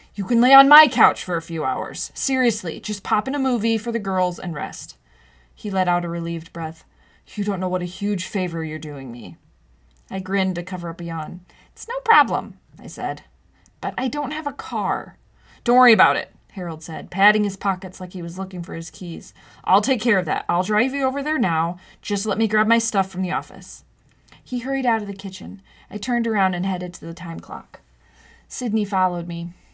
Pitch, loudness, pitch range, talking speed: 190 Hz, -21 LUFS, 175-225 Hz, 220 wpm